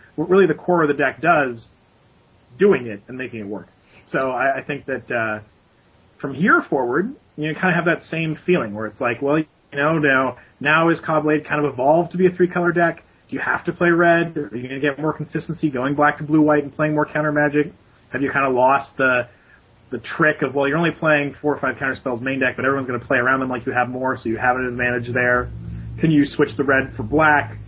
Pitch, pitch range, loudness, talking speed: 140 Hz, 125-155 Hz, -19 LUFS, 255 wpm